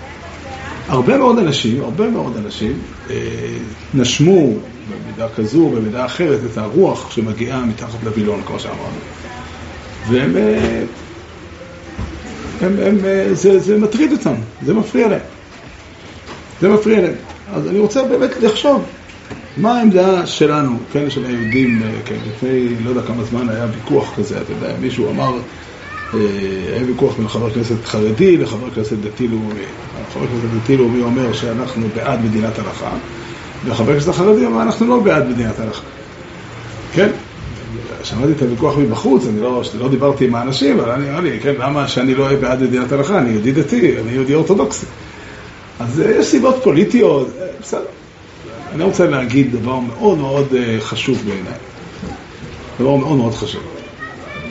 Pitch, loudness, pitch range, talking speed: 125 Hz, -15 LUFS, 110-150 Hz, 140 wpm